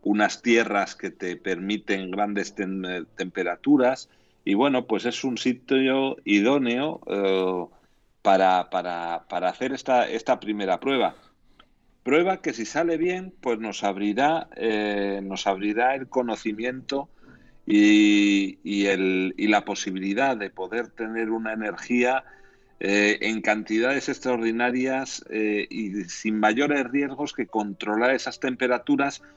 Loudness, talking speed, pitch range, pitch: -24 LUFS, 125 wpm, 100-130 Hz, 110 Hz